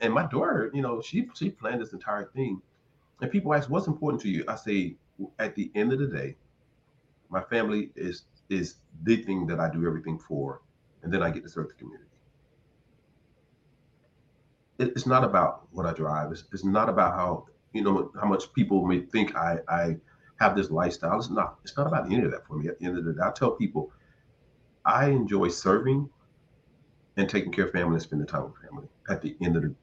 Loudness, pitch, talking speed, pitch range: -28 LUFS, 115 Hz, 215 wpm, 90-140 Hz